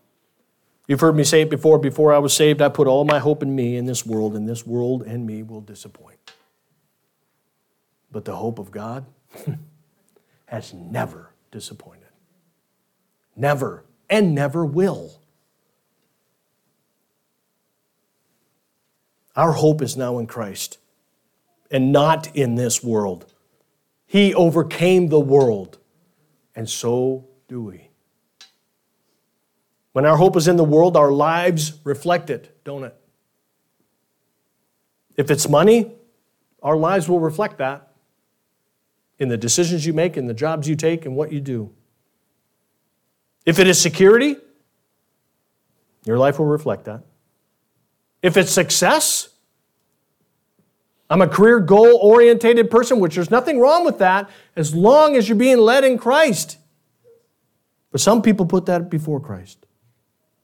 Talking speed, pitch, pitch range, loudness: 130 wpm, 155 Hz, 130-185 Hz, -17 LUFS